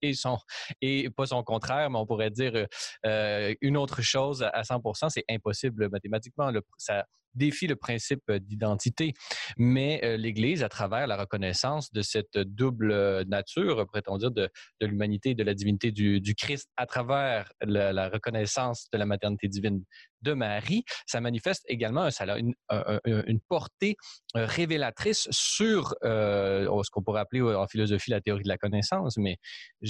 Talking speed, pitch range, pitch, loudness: 165 wpm, 105-130 Hz, 110 Hz, -29 LUFS